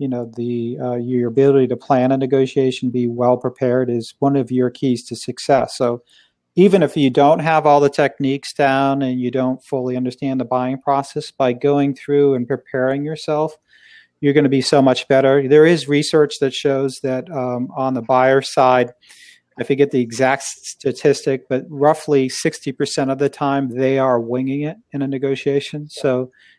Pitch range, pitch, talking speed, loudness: 125-140 Hz, 135 Hz, 185 wpm, -17 LUFS